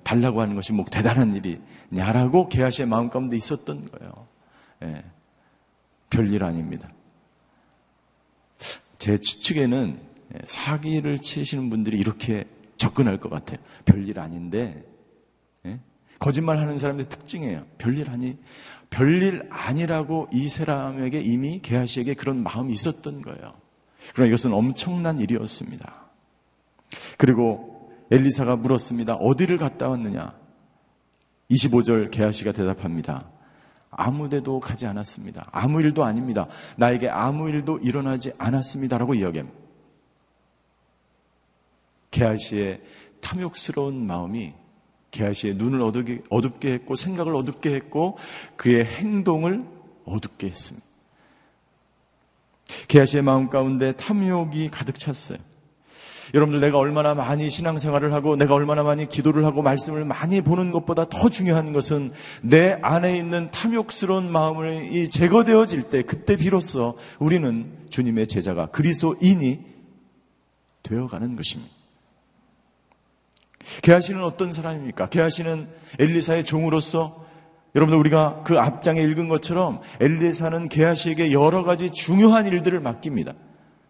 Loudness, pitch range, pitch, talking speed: -22 LUFS, 115-160 Hz, 135 Hz, 300 characters per minute